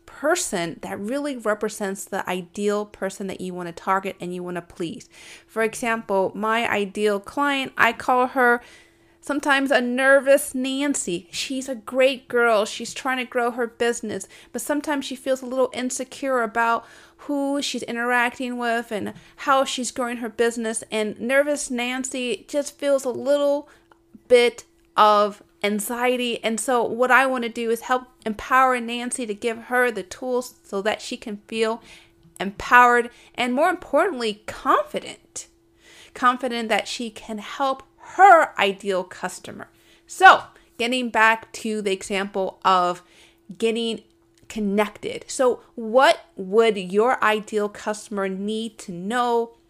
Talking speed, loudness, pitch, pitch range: 145 wpm, -22 LUFS, 235 Hz, 210-260 Hz